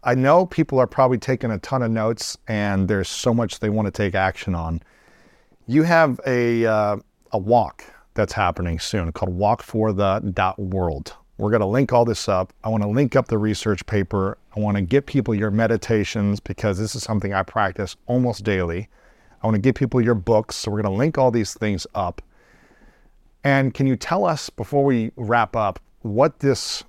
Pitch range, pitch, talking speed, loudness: 100-125 Hz, 110 Hz, 200 wpm, -21 LUFS